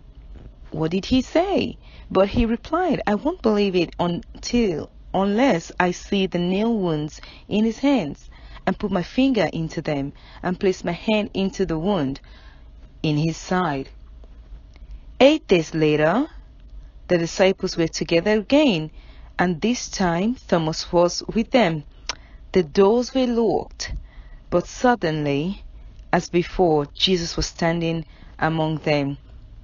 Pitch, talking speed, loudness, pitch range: 180 Hz, 130 wpm, -22 LUFS, 155-210 Hz